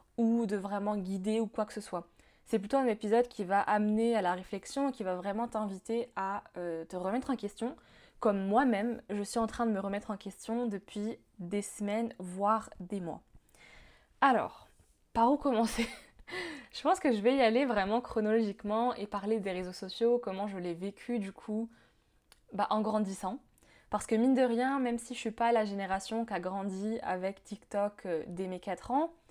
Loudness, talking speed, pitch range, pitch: -33 LUFS, 195 wpm, 195-235 Hz, 215 Hz